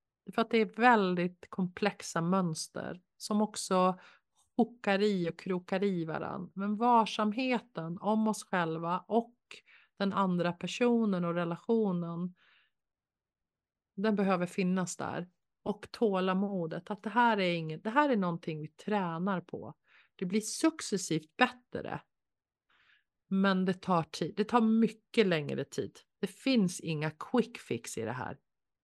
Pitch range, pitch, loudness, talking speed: 175-220 Hz, 195 Hz, -32 LUFS, 135 wpm